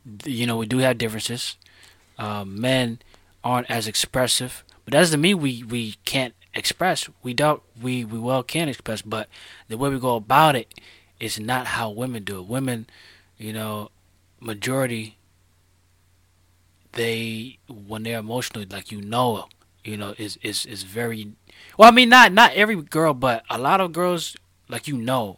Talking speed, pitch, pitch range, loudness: 170 wpm, 115 Hz, 100-130 Hz, -21 LUFS